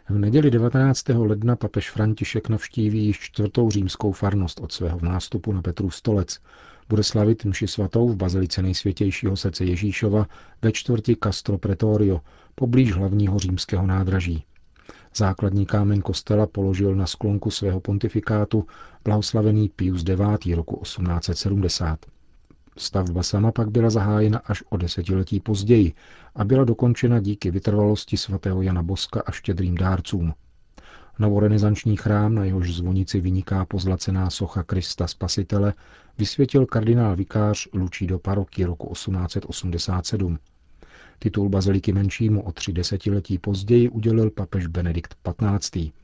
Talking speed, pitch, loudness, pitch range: 125 wpm, 100 Hz, -23 LUFS, 95-105 Hz